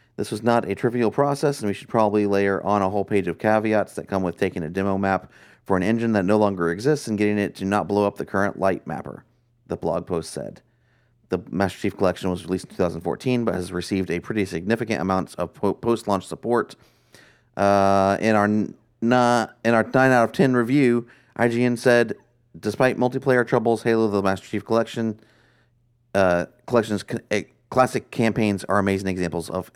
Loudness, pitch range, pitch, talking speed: -22 LUFS, 95-120 Hz, 105 Hz, 195 wpm